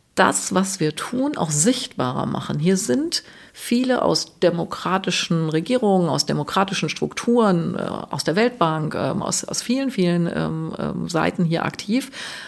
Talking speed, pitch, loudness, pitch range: 125 wpm, 185 Hz, -21 LUFS, 165-240 Hz